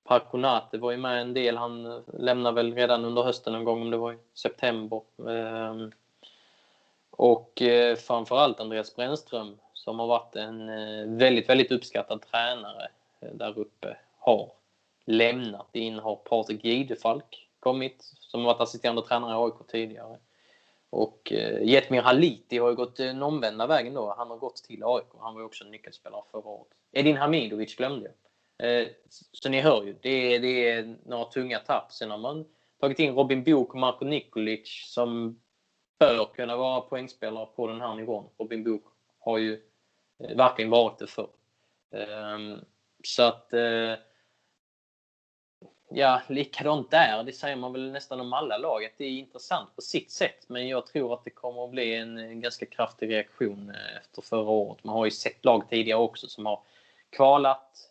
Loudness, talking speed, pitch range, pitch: -27 LUFS, 165 wpm, 110-125 Hz, 120 Hz